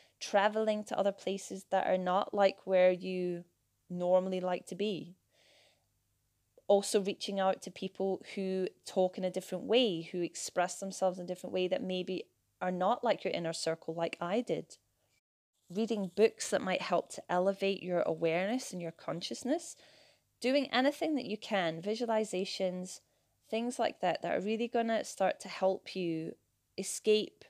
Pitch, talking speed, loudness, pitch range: 190 Hz, 160 wpm, -34 LUFS, 180-215 Hz